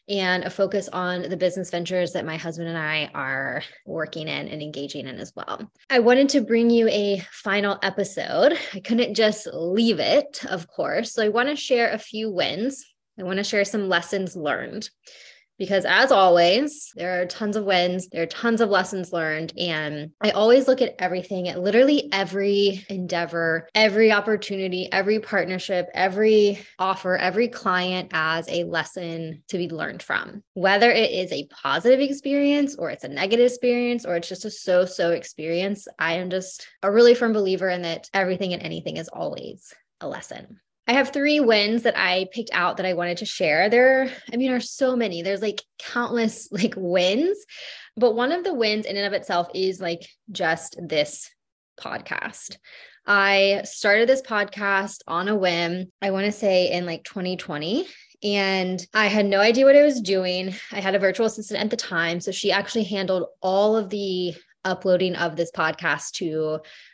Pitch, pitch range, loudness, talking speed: 195 Hz, 180-225 Hz, -22 LUFS, 185 wpm